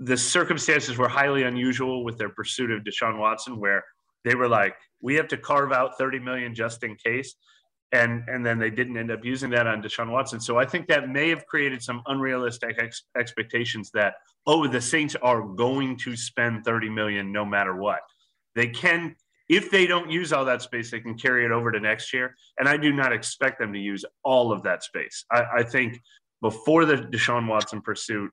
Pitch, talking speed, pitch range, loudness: 120 Hz, 210 wpm, 115-130 Hz, -24 LUFS